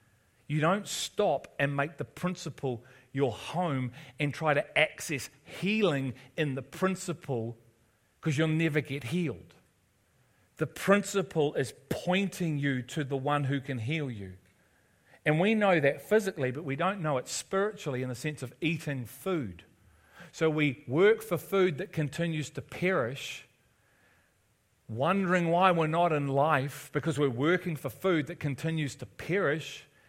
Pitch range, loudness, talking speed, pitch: 130-170 Hz, -30 LUFS, 150 wpm, 145 Hz